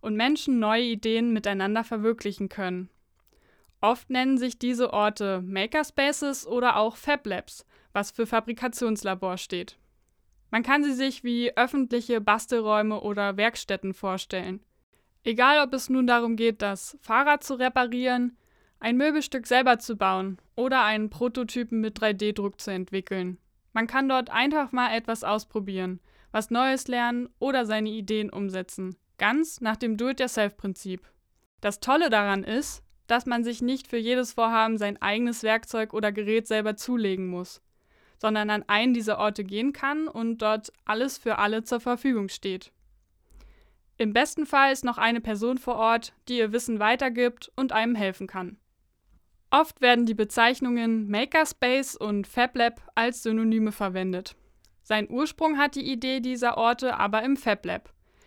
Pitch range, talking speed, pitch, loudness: 205-250 Hz, 145 wpm, 230 Hz, -26 LUFS